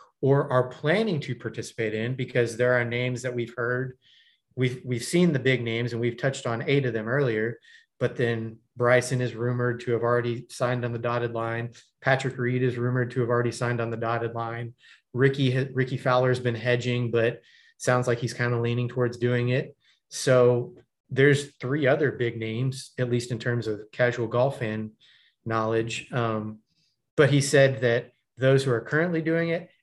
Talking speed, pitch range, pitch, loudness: 190 wpm, 120-130 Hz, 125 Hz, -26 LUFS